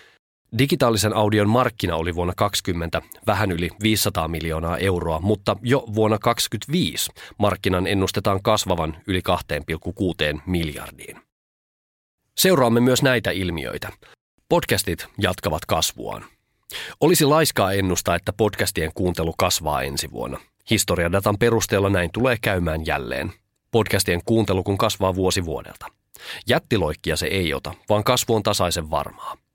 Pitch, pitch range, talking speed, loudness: 100 Hz, 85-110 Hz, 120 wpm, -21 LUFS